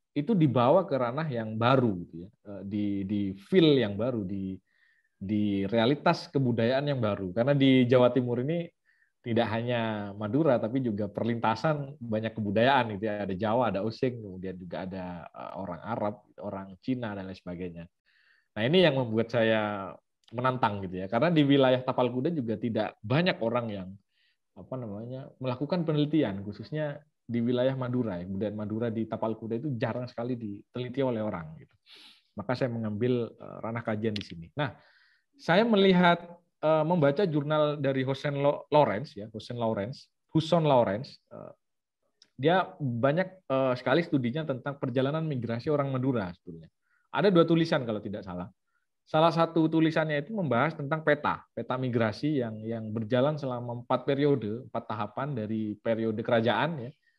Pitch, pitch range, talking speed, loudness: 120 Hz, 110-145 Hz, 150 wpm, -28 LUFS